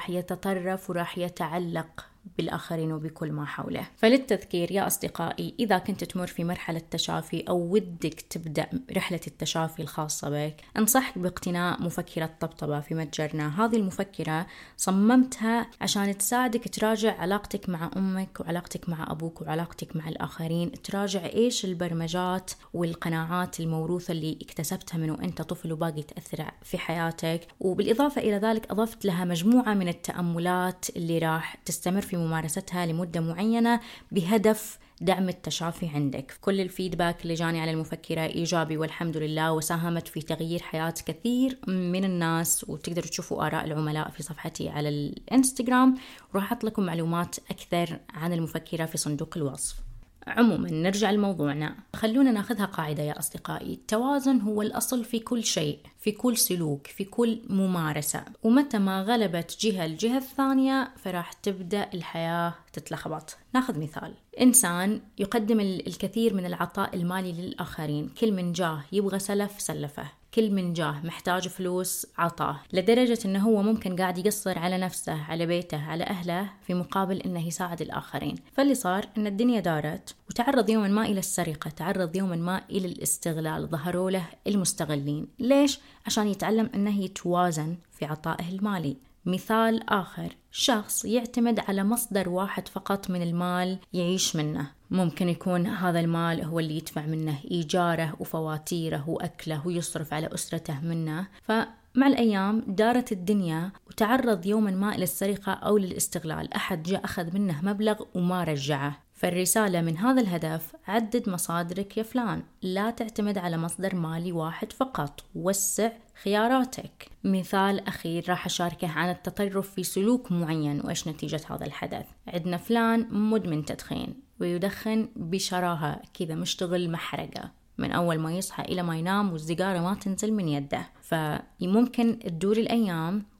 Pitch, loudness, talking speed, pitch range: 180 Hz, -28 LUFS, 135 wpm, 165-210 Hz